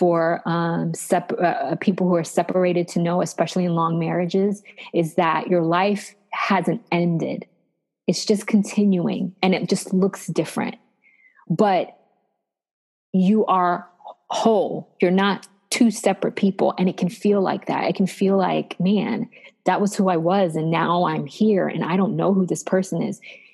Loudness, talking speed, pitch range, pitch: -21 LUFS, 165 wpm, 175-200 Hz, 185 Hz